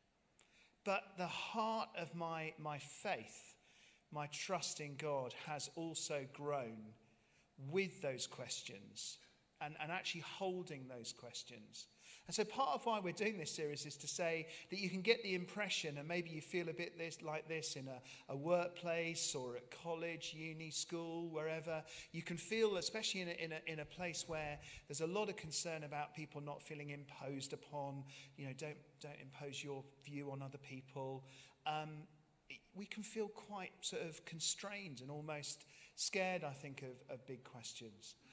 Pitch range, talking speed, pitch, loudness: 145-175 Hz, 170 wpm, 155 Hz, -44 LUFS